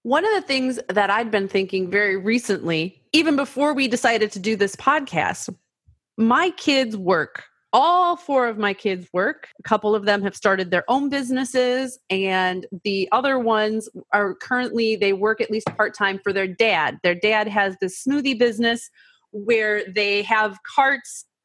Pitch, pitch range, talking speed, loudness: 215 Hz, 200-255 Hz, 170 wpm, -21 LUFS